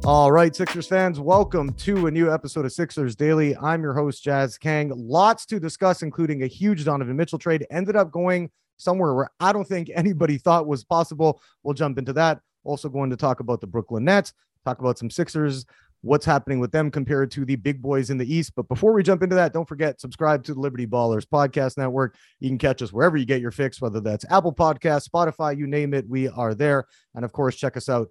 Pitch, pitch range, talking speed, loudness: 145 Hz, 135-165 Hz, 230 wpm, -22 LUFS